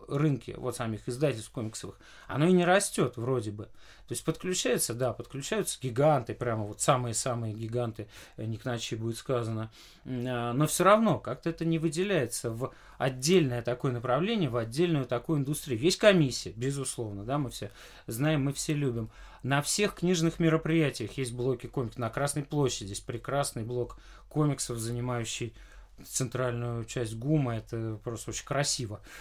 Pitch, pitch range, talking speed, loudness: 125 Hz, 115-150 Hz, 150 wpm, -30 LUFS